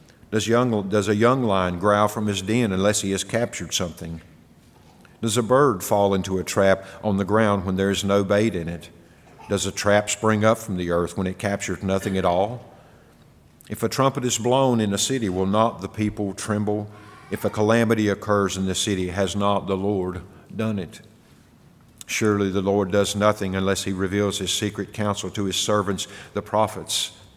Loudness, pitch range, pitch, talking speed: -22 LUFS, 95-105 Hz, 100 Hz, 195 wpm